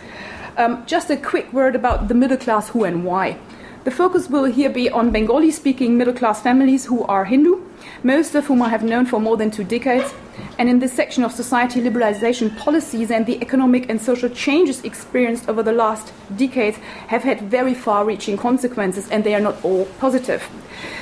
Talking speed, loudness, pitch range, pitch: 195 wpm, -18 LUFS, 220-265 Hz, 245 Hz